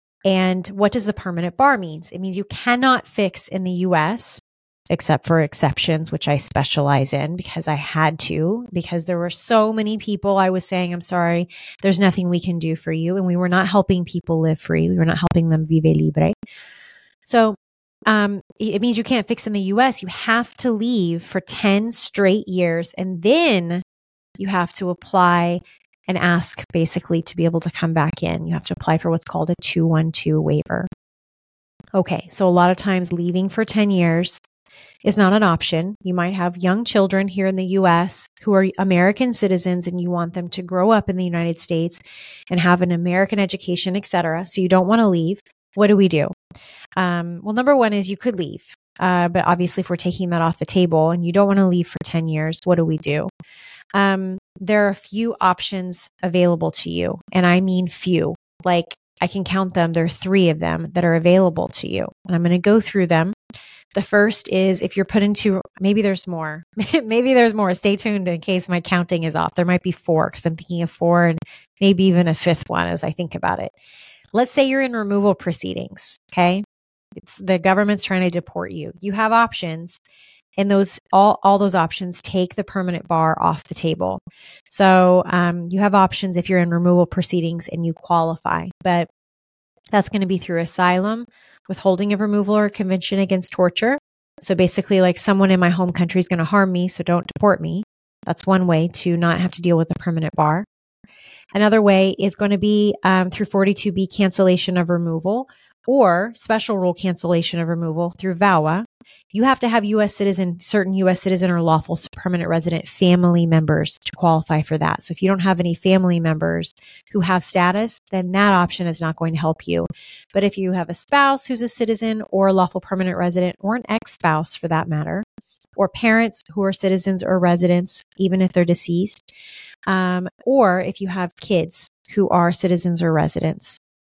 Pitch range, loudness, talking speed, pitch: 170-200 Hz, -19 LUFS, 200 wpm, 180 Hz